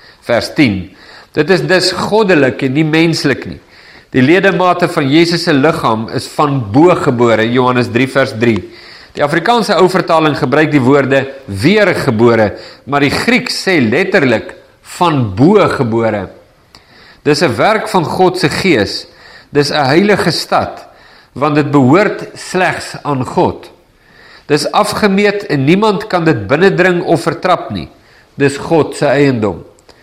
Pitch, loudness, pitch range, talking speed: 150 Hz, -11 LUFS, 135-180 Hz, 140 wpm